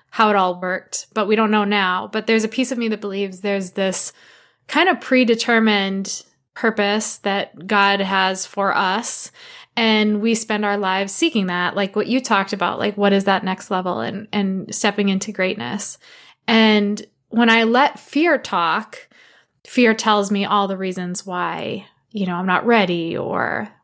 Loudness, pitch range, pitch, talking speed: -19 LUFS, 195-225 Hz, 205 Hz, 175 wpm